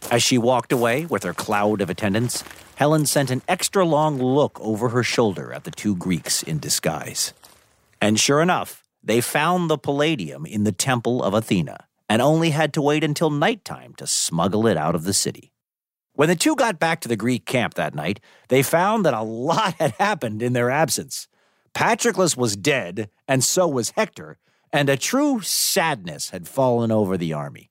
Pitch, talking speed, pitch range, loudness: 130 Hz, 190 wpm, 110-160 Hz, -21 LUFS